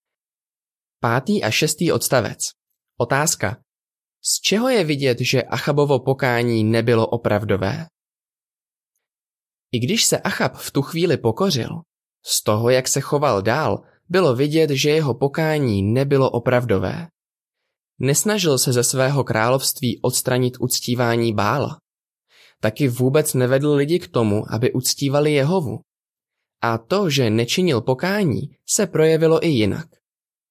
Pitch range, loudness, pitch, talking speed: 120-155 Hz, -19 LUFS, 135 Hz, 120 wpm